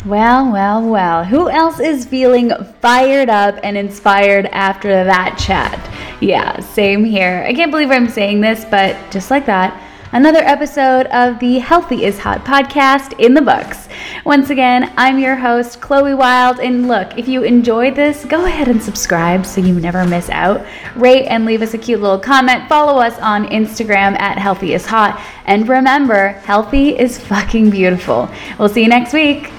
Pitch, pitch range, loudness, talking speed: 235 Hz, 200-265 Hz, -12 LUFS, 175 wpm